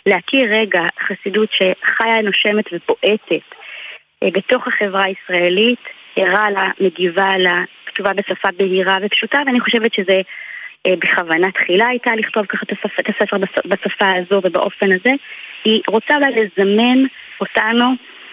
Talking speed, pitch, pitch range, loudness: 130 wpm, 200 Hz, 190-225 Hz, -15 LUFS